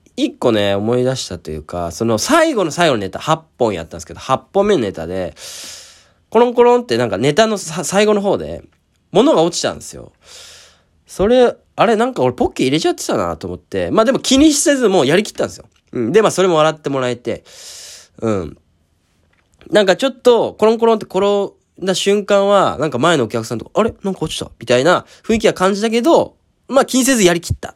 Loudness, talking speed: -15 LUFS, 410 characters per minute